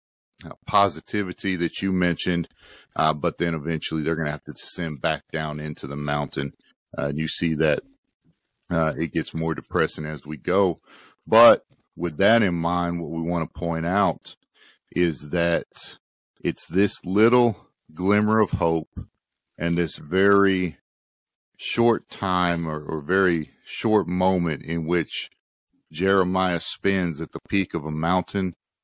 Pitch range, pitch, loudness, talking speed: 80-95 Hz, 85 Hz, -24 LUFS, 150 wpm